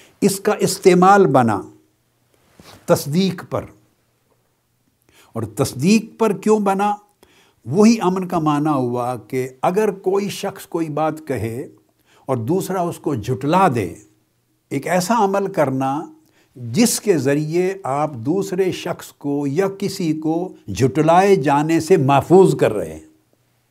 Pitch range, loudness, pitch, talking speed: 140-195 Hz, -18 LUFS, 170 Hz, 125 wpm